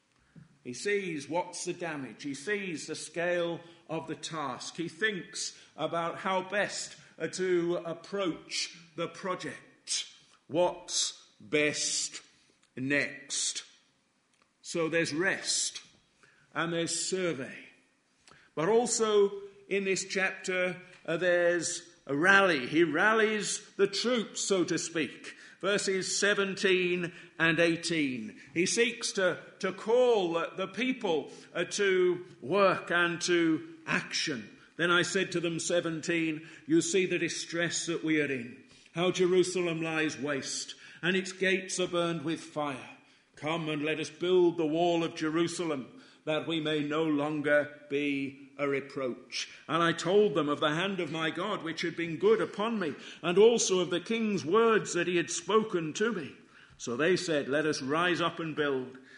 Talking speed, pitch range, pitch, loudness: 145 wpm, 155-190 Hz, 170 Hz, -30 LUFS